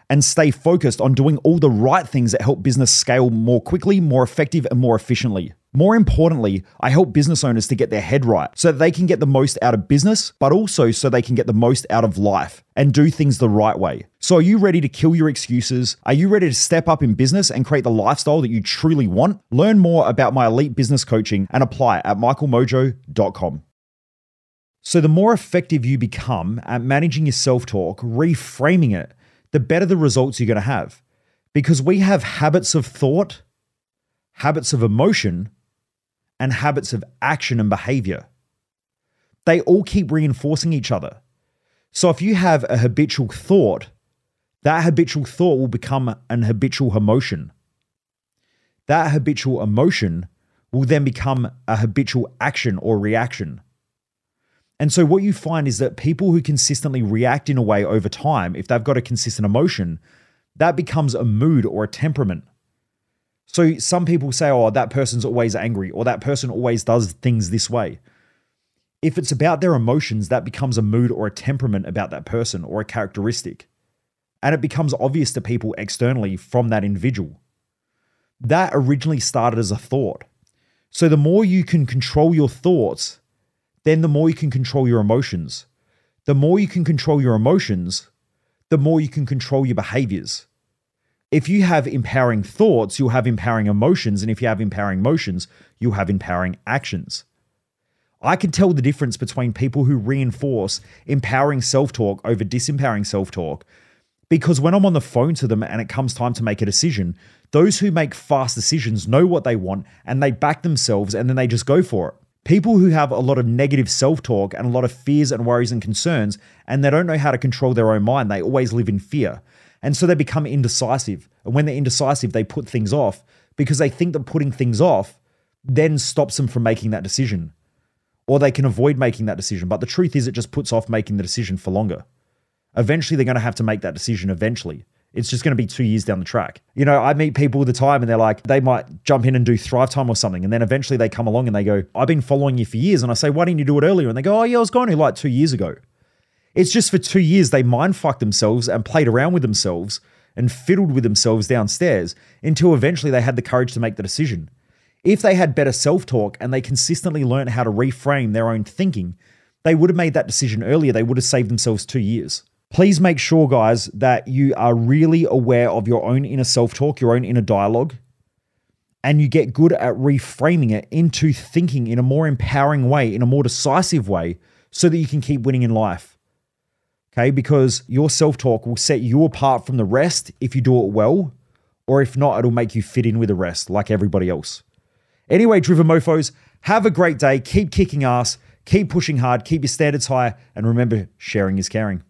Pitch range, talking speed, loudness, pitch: 115-150 Hz, 205 wpm, -18 LUFS, 130 Hz